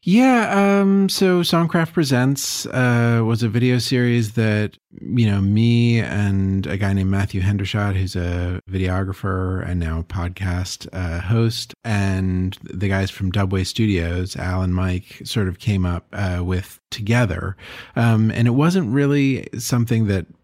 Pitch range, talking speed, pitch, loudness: 95-120 Hz, 155 wpm, 100 Hz, -20 LUFS